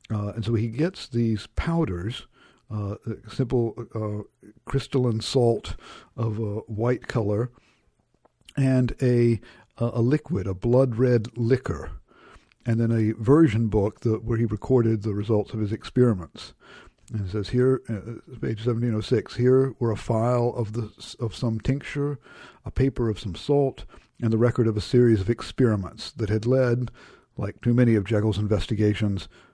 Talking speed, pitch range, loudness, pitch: 150 wpm, 110-125 Hz, -25 LUFS, 115 Hz